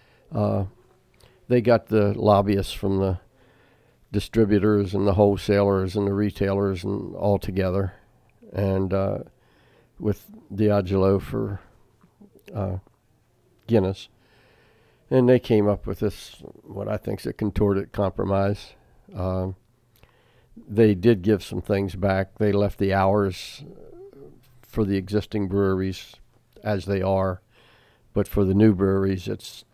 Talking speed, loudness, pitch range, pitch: 125 wpm, -23 LUFS, 95-115 Hz, 105 Hz